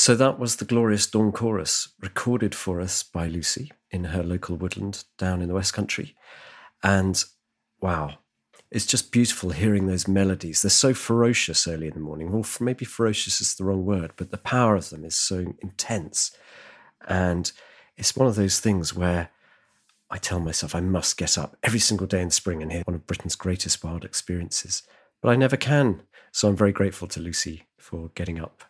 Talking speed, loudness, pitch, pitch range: 190 wpm, -24 LUFS, 95 Hz, 85-110 Hz